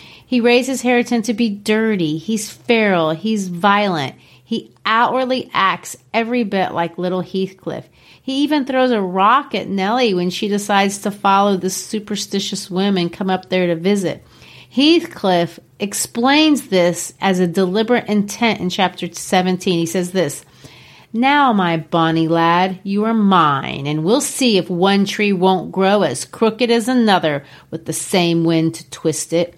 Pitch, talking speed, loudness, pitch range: 195 Hz, 155 wpm, -17 LUFS, 175-225 Hz